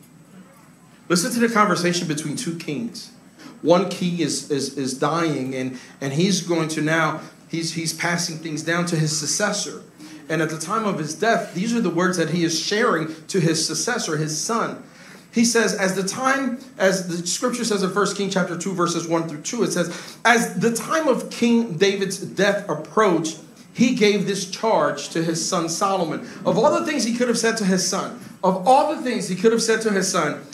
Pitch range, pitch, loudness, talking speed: 160-220 Hz, 185 Hz, -21 LUFS, 205 wpm